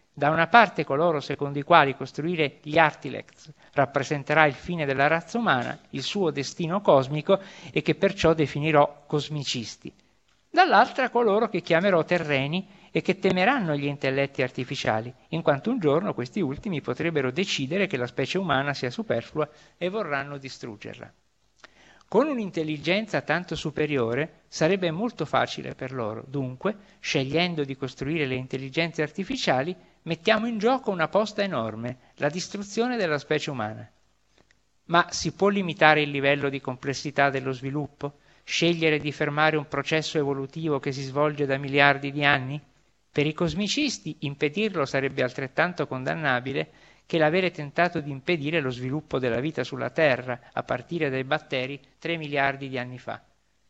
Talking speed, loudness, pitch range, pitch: 145 wpm, -25 LUFS, 140-170 Hz, 150 Hz